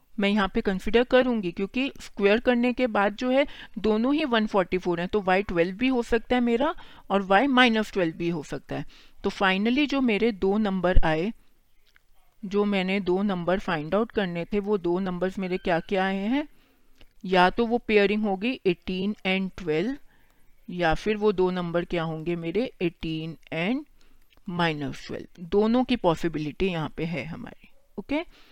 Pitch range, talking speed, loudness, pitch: 180-230 Hz, 180 wpm, -25 LUFS, 200 Hz